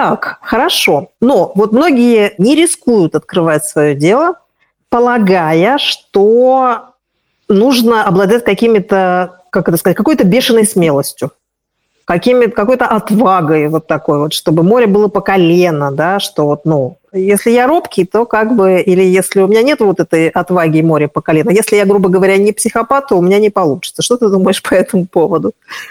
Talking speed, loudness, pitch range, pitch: 160 wpm, -10 LUFS, 170-230 Hz, 195 Hz